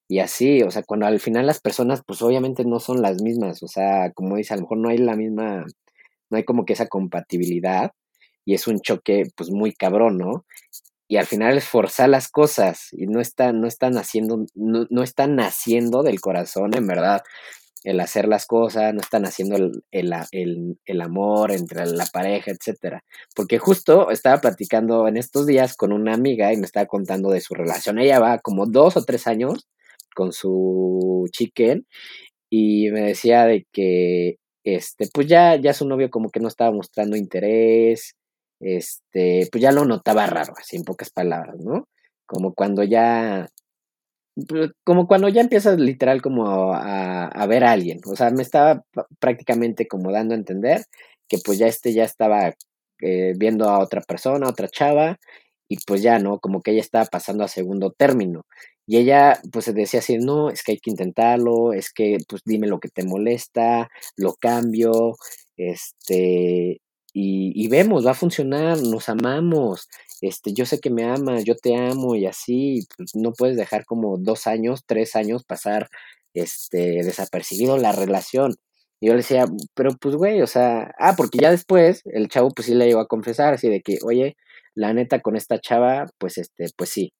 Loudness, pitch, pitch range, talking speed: -20 LUFS, 115 Hz, 100-125 Hz, 185 wpm